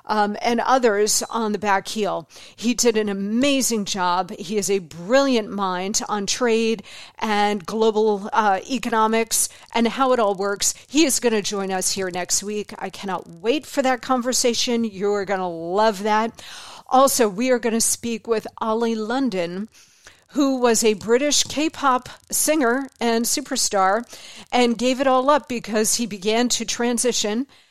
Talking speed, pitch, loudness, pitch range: 165 wpm, 225 Hz, -21 LUFS, 205-245 Hz